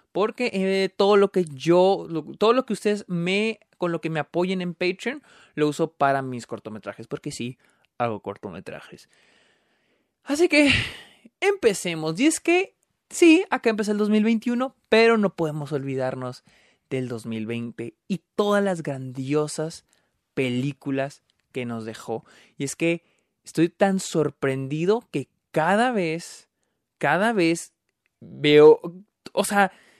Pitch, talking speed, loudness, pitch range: 170 Hz, 135 wpm, -23 LUFS, 140-210 Hz